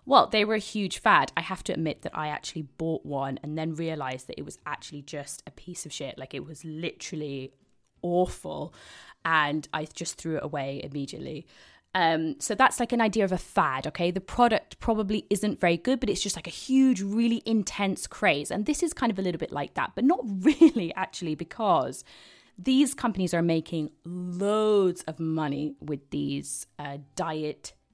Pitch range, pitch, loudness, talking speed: 155-210 Hz, 170 Hz, -27 LUFS, 195 wpm